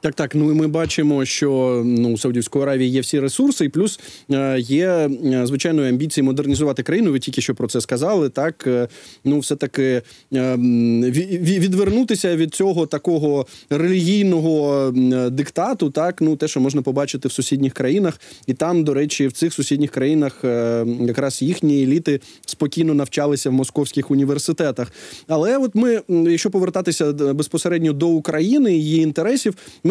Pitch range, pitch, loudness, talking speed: 135-165 Hz, 145 Hz, -19 LUFS, 155 wpm